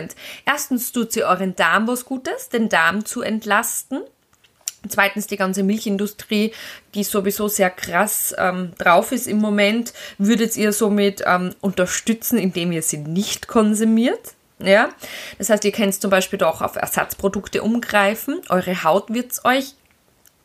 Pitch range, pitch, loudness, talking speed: 195-230 Hz, 205 Hz, -19 LUFS, 145 wpm